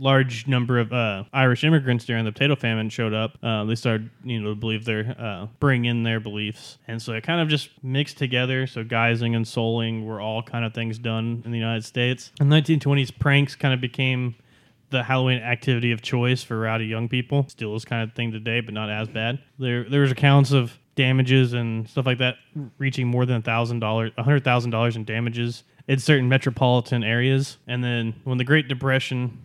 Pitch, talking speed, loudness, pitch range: 120 Hz, 210 wpm, -23 LUFS, 115-135 Hz